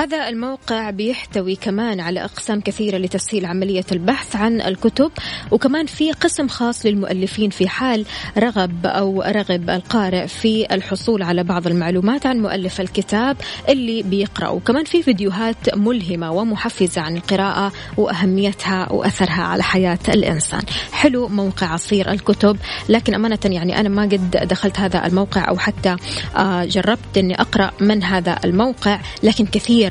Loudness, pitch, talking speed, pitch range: -18 LUFS, 200 Hz, 140 wpm, 185-225 Hz